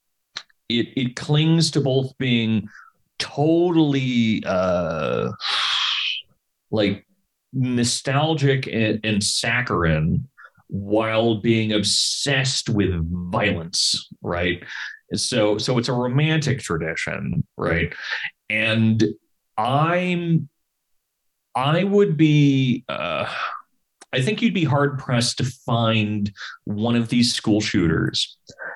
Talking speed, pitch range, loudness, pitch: 90 wpm, 105-140 Hz, -21 LUFS, 120 Hz